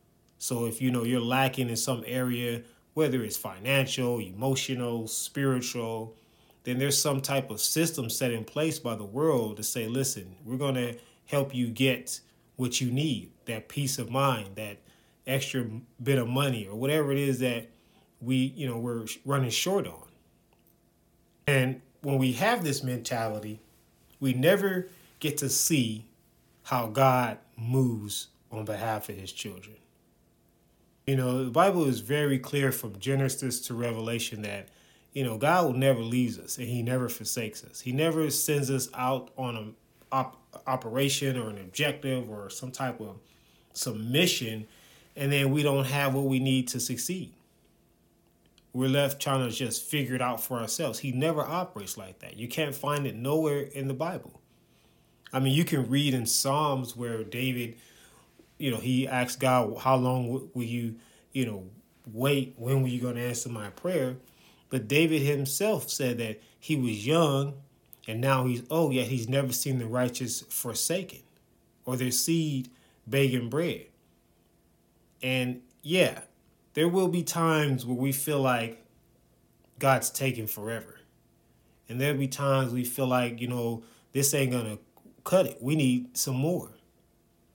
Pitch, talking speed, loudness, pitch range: 130 Hz, 160 wpm, -29 LUFS, 115-140 Hz